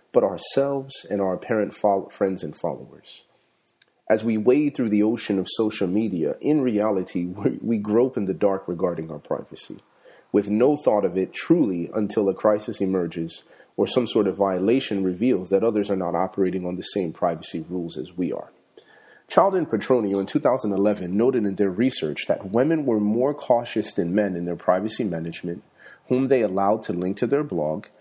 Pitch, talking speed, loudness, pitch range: 100 Hz, 180 wpm, -23 LUFS, 90-110 Hz